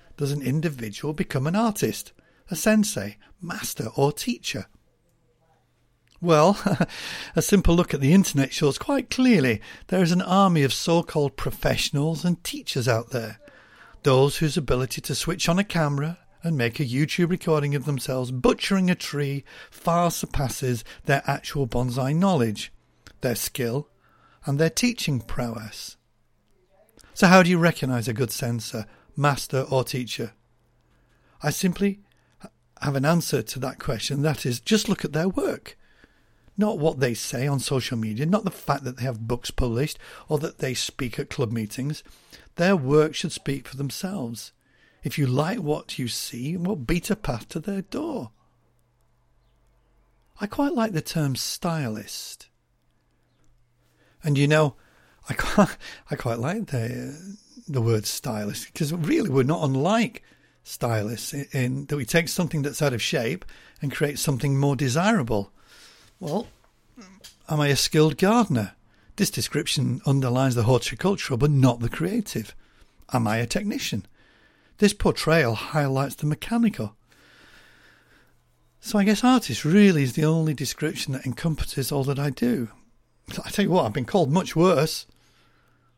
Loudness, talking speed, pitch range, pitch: -24 LUFS, 150 wpm, 125-170 Hz, 145 Hz